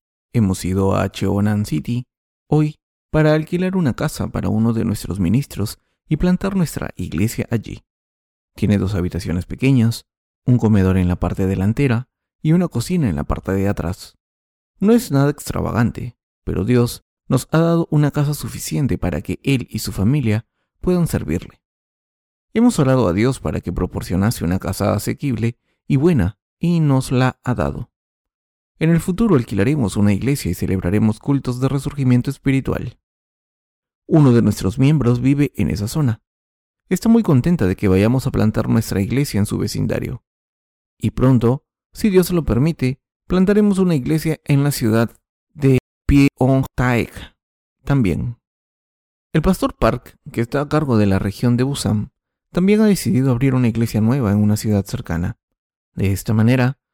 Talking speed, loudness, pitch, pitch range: 155 wpm, -18 LUFS, 120 Hz, 100-140 Hz